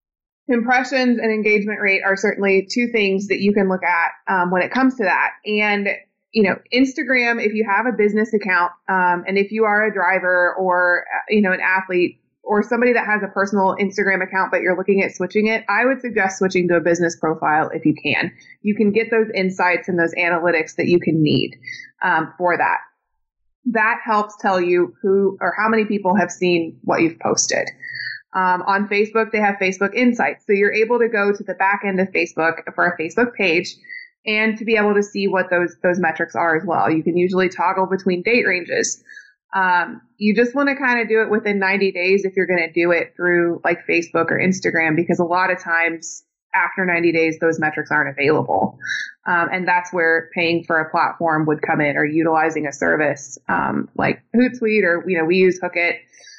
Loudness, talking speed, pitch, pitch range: -18 LUFS, 210 wpm, 190 Hz, 175-215 Hz